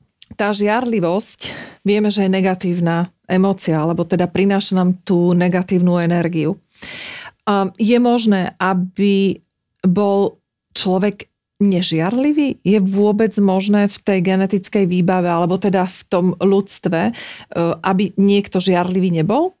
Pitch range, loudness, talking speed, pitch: 180-205 Hz, -17 LUFS, 115 wpm, 190 Hz